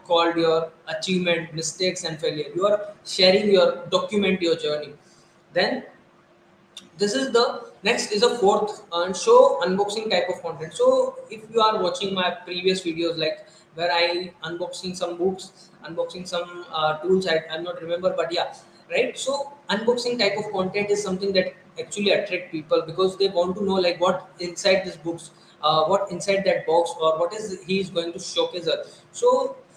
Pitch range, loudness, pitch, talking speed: 170-200 Hz, -23 LUFS, 185 Hz, 175 wpm